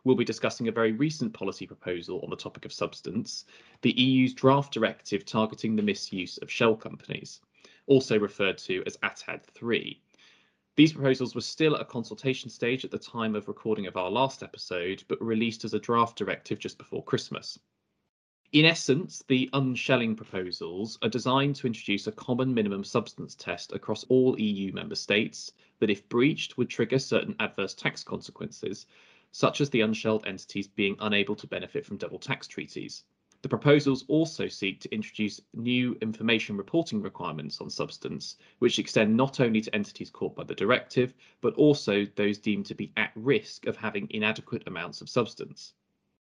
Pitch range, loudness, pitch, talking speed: 110-130 Hz, -28 LUFS, 115 Hz, 170 wpm